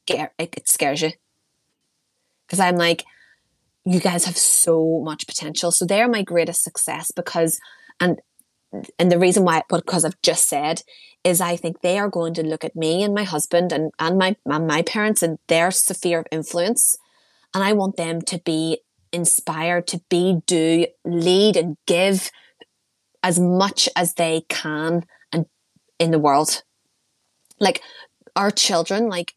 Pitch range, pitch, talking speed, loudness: 165-185 Hz, 175 Hz, 155 wpm, -20 LUFS